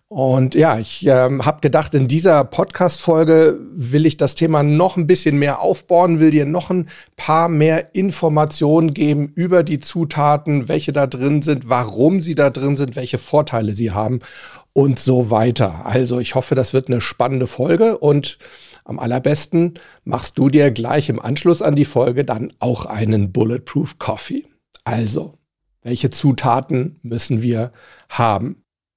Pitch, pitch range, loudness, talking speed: 140 Hz, 125-160 Hz, -16 LUFS, 160 wpm